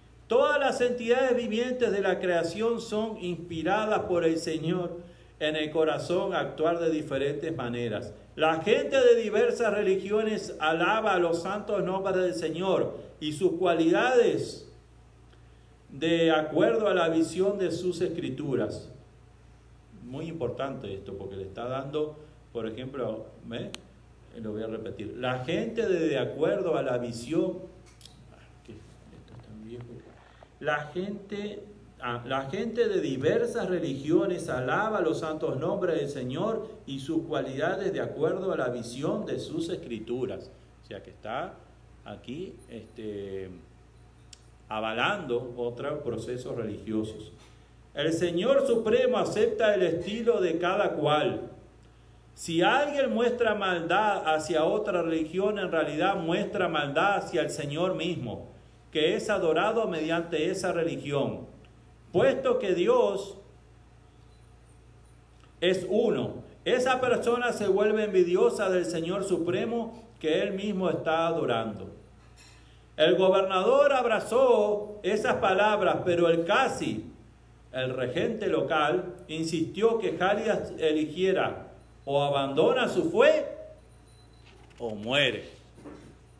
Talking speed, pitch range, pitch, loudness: 120 wpm, 140-210 Hz, 170 Hz, -28 LUFS